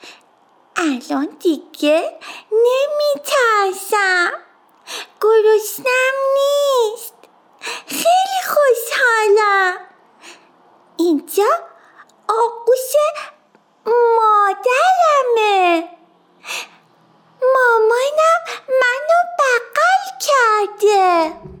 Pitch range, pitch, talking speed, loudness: 330-455 Hz, 385 Hz, 40 wpm, -15 LUFS